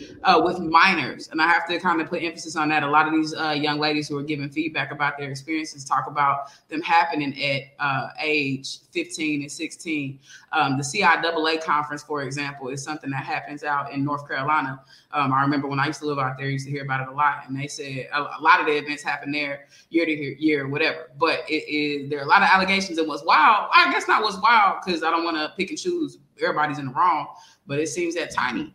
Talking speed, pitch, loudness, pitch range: 245 wpm, 150 Hz, -22 LUFS, 140-160 Hz